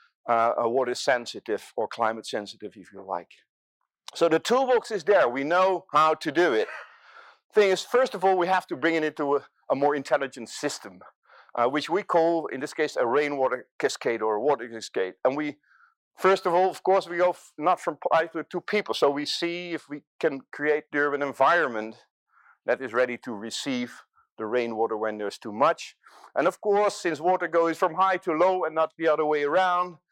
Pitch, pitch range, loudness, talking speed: 160 Hz, 135-185 Hz, -25 LUFS, 210 wpm